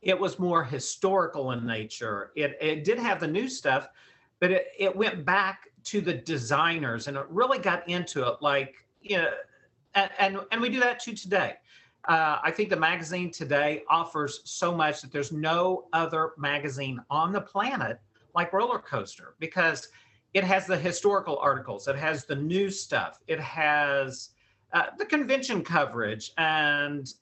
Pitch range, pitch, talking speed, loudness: 145-195 Hz, 165 Hz, 170 wpm, -27 LUFS